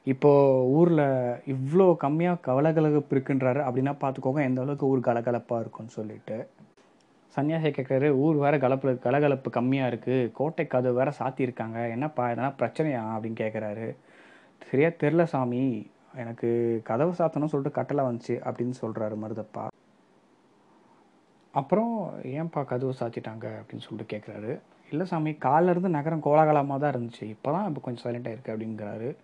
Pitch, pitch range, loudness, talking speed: 130 Hz, 120-145 Hz, -27 LUFS, 130 wpm